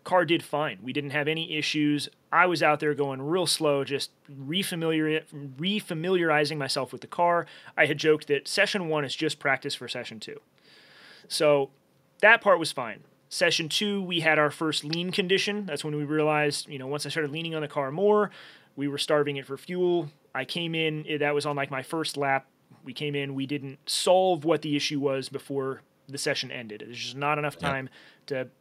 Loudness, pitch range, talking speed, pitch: -27 LUFS, 140-165 Hz, 205 wpm, 150 Hz